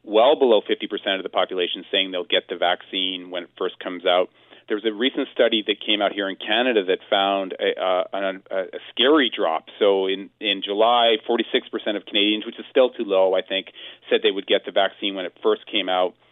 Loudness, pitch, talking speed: -21 LUFS, 100 Hz, 230 wpm